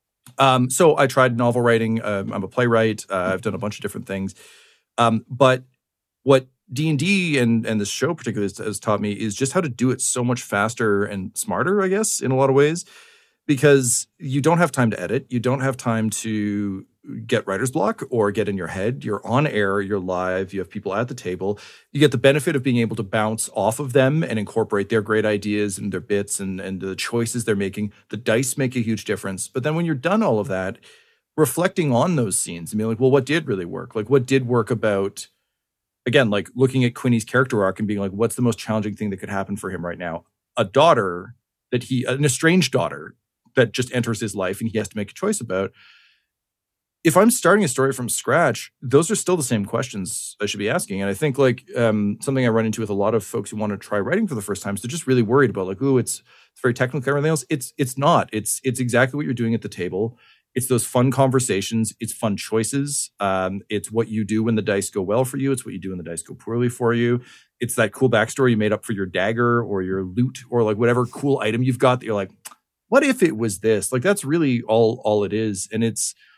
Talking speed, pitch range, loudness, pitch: 245 wpm, 105-130 Hz, -21 LUFS, 115 Hz